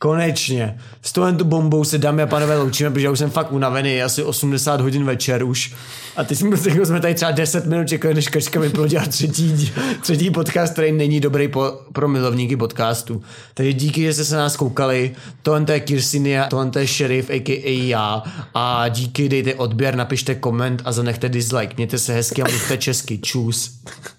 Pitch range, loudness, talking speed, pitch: 125-155 Hz, -19 LUFS, 185 wpm, 135 Hz